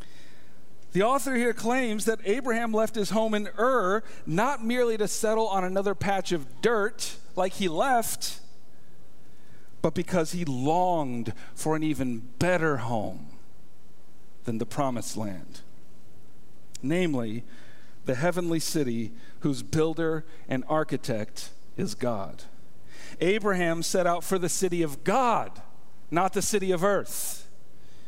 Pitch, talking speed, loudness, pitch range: 170 Hz, 125 wpm, -28 LUFS, 130-200 Hz